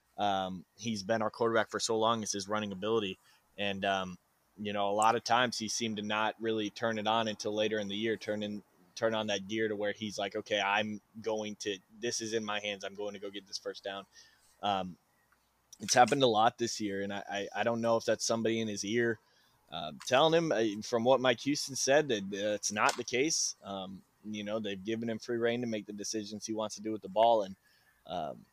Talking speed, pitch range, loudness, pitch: 245 wpm, 100-115 Hz, -32 LUFS, 105 Hz